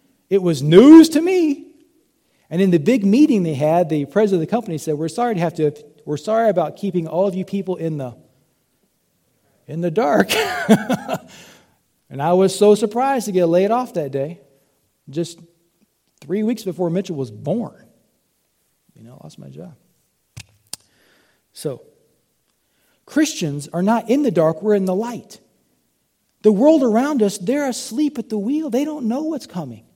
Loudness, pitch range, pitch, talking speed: -18 LUFS, 165-240 Hz, 195 Hz, 170 wpm